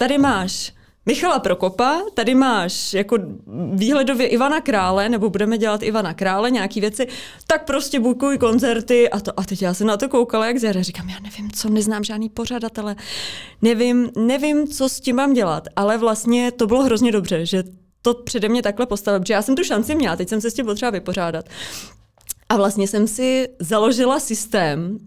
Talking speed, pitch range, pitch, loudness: 185 wpm, 200-250 Hz, 225 Hz, -19 LUFS